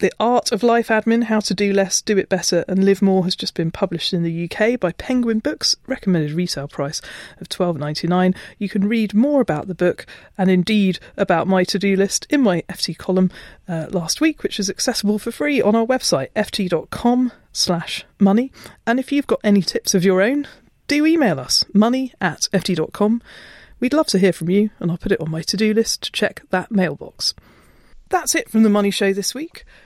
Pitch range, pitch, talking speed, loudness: 180-230 Hz, 200 Hz, 205 wpm, -19 LUFS